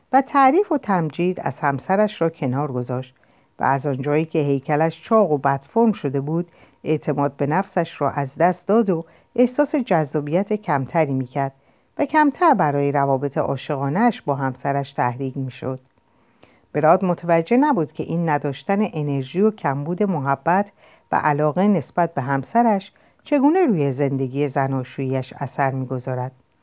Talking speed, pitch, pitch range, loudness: 135 wpm, 150 Hz, 140-195 Hz, -21 LUFS